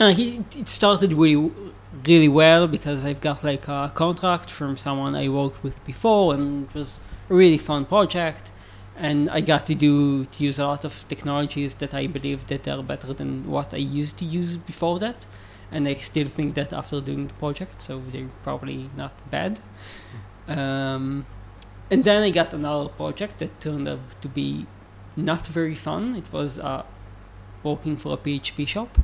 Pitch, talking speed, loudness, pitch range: 145 Hz, 180 wpm, -23 LUFS, 130-160 Hz